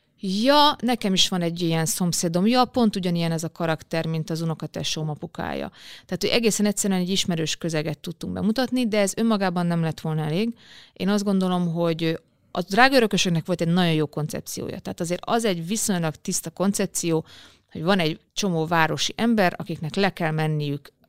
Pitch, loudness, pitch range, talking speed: 180 Hz, -23 LUFS, 160-205 Hz, 175 wpm